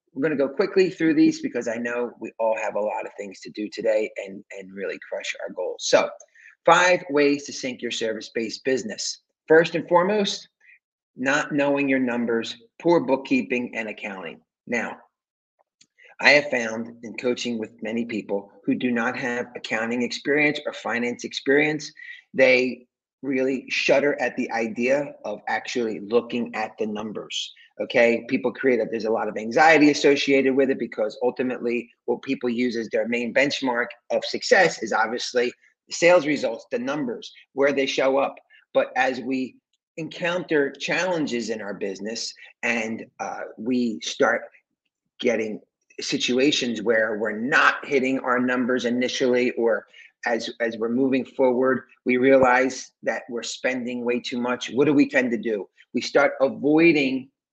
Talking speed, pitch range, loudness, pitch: 160 wpm, 120-145 Hz, -23 LUFS, 125 Hz